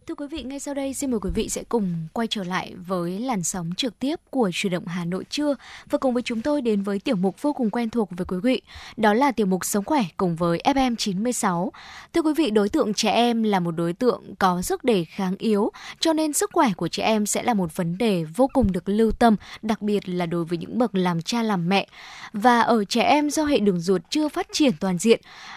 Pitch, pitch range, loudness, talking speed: 220 Hz, 190-255 Hz, -23 LUFS, 255 wpm